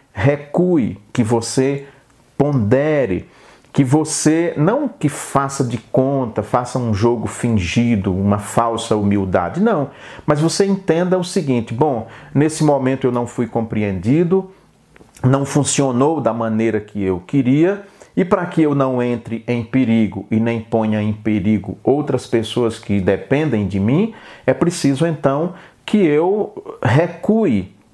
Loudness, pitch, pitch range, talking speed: -18 LUFS, 130 Hz, 115-150 Hz, 135 wpm